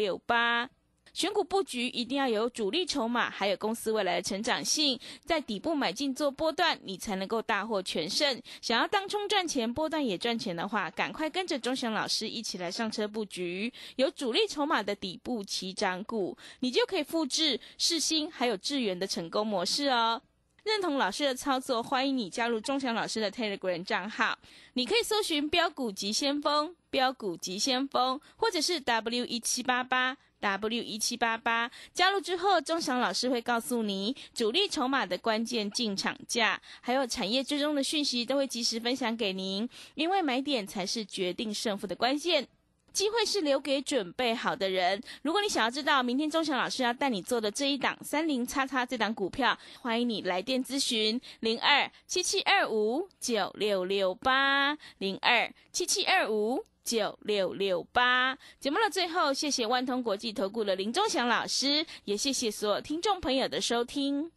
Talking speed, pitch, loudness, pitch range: 280 characters per minute, 250 Hz, -29 LUFS, 220-295 Hz